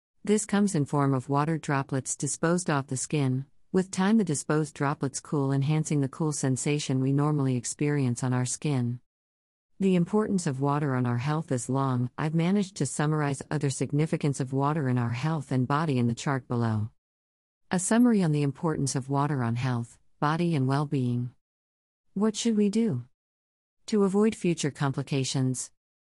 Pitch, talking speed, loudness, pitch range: 140 Hz, 170 wpm, -27 LUFS, 125-155 Hz